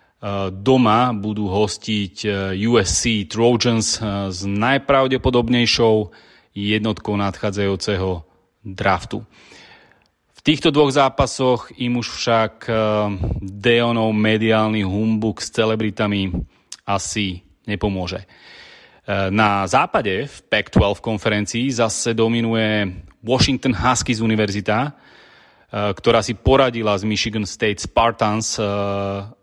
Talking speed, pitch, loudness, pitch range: 85 wpm, 110 Hz, -19 LUFS, 100-115 Hz